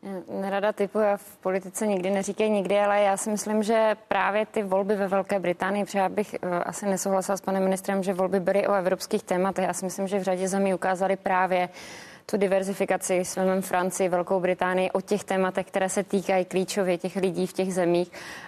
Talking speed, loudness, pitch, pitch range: 195 wpm, -26 LUFS, 190 Hz, 185-200 Hz